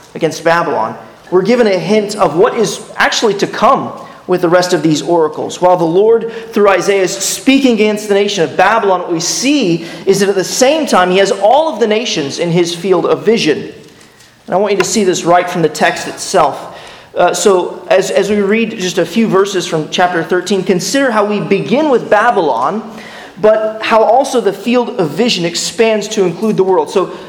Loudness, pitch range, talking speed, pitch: -12 LUFS, 175-220 Hz, 205 wpm, 190 Hz